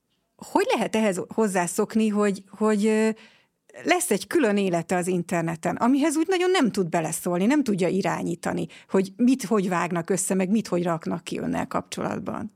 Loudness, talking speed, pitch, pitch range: -24 LUFS, 160 wpm, 205 Hz, 180-225 Hz